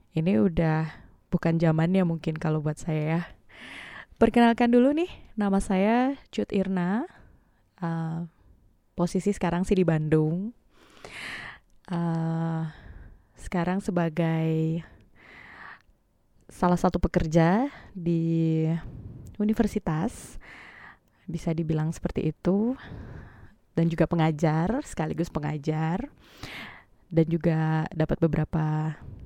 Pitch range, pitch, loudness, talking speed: 160-190 Hz, 165 Hz, -26 LUFS, 90 wpm